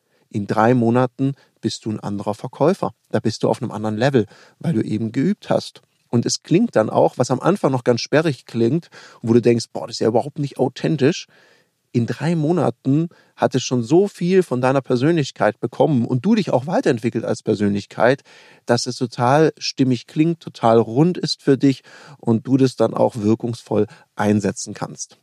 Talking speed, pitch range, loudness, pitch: 190 wpm, 115-150 Hz, -19 LUFS, 125 Hz